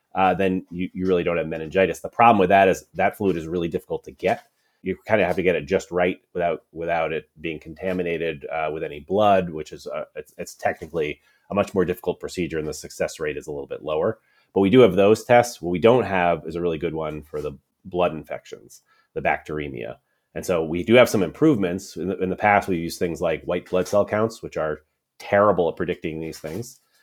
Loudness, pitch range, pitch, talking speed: -22 LUFS, 80-105 Hz, 90 Hz, 235 wpm